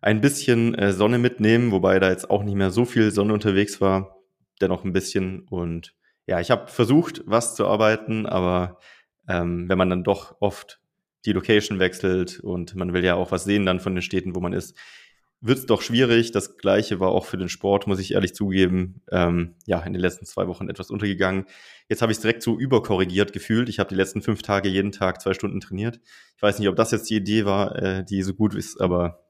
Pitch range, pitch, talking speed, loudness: 95-105 Hz, 100 Hz, 220 wpm, -23 LUFS